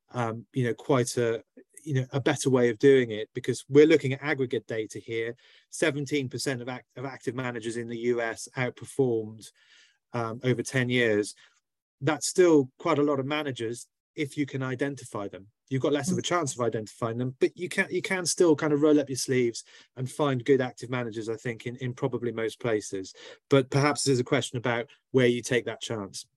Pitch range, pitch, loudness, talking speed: 115-145 Hz, 125 Hz, -27 LUFS, 205 wpm